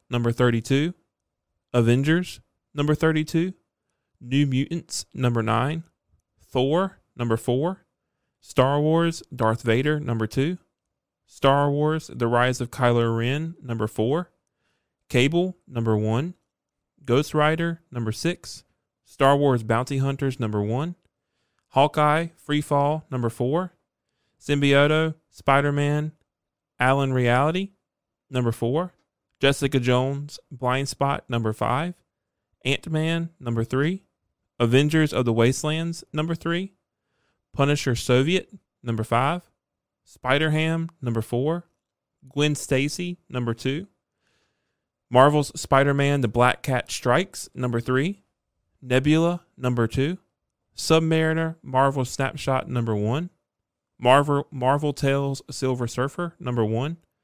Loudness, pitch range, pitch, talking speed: -23 LUFS, 120-155 Hz, 135 Hz, 105 wpm